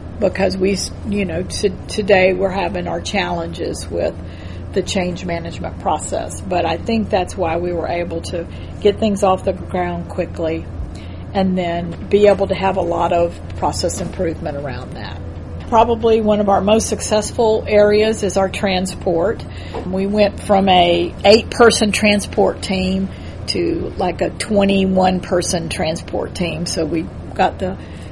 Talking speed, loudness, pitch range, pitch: 155 wpm, -17 LUFS, 125-205 Hz, 190 Hz